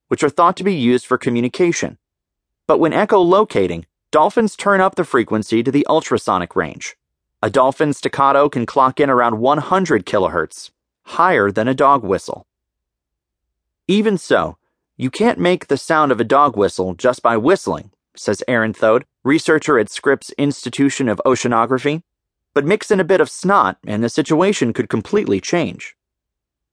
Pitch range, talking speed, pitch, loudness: 115-170 Hz, 155 wpm, 140 Hz, -16 LUFS